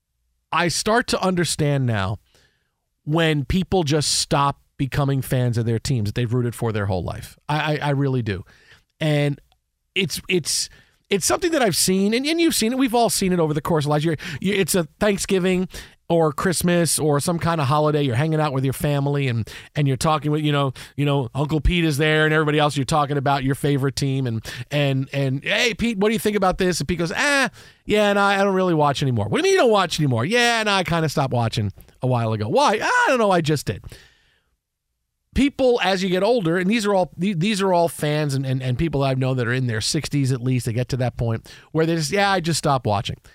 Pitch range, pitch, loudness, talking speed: 130-185 Hz, 150 Hz, -21 LUFS, 245 wpm